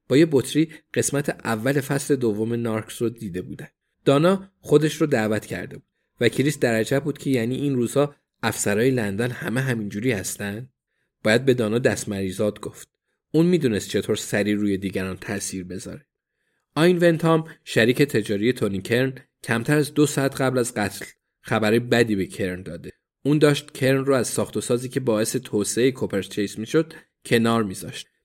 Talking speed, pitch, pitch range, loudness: 160 wpm, 120 Hz, 105-140 Hz, -23 LUFS